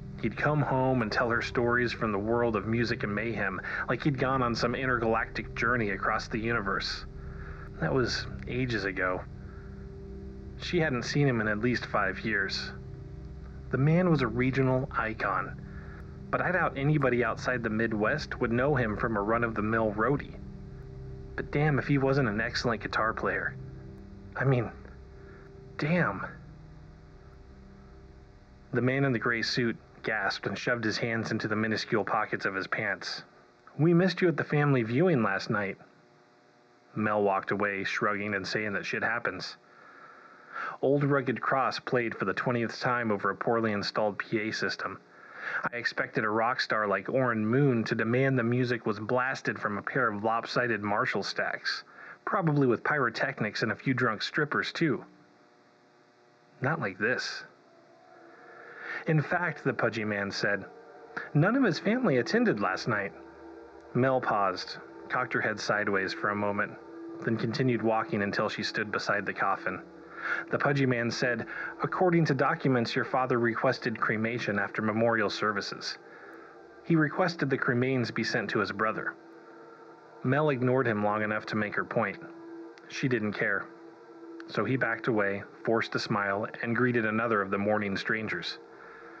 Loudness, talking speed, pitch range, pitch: -29 LUFS, 155 wpm, 100-130 Hz, 115 Hz